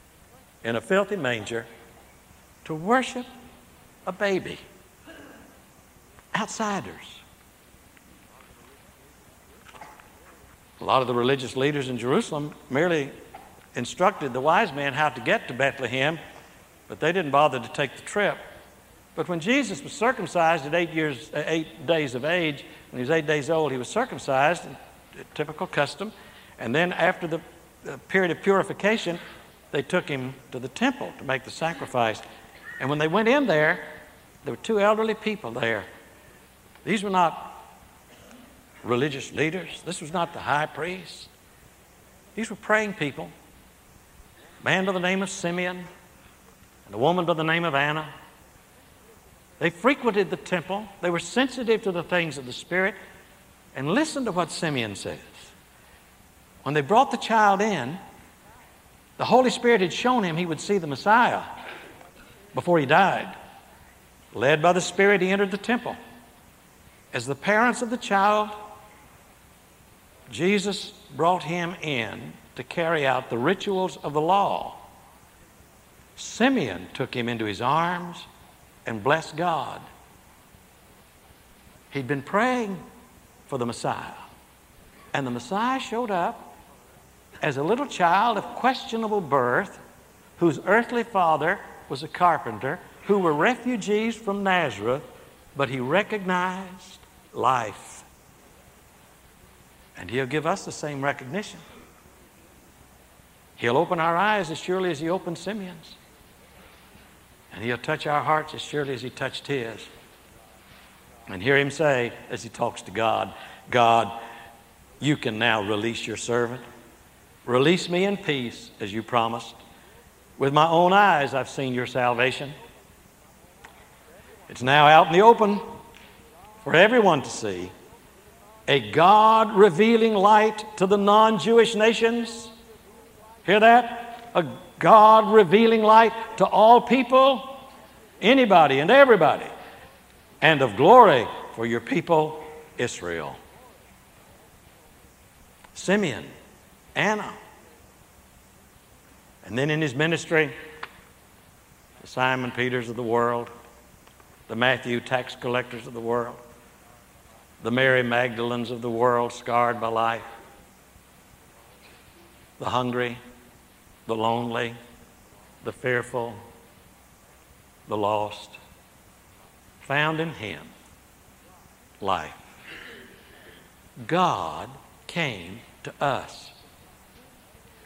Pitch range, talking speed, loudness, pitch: 120-195 Hz, 125 wpm, -23 LUFS, 155 Hz